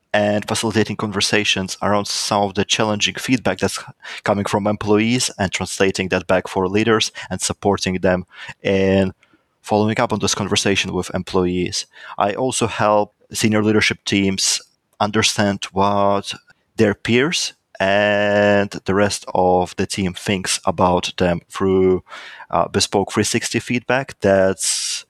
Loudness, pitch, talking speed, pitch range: -18 LUFS, 100 Hz, 130 wpm, 95-105 Hz